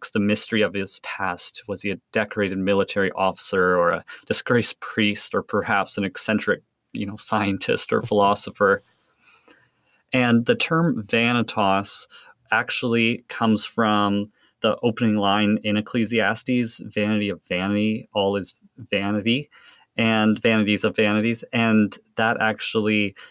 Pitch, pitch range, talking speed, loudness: 105 Hz, 100-115 Hz, 125 wpm, -22 LUFS